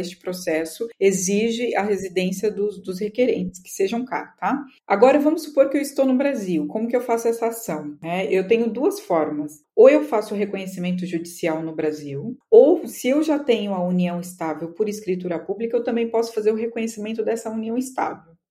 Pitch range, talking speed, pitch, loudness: 180-235 Hz, 190 wpm, 210 Hz, -22 LUFS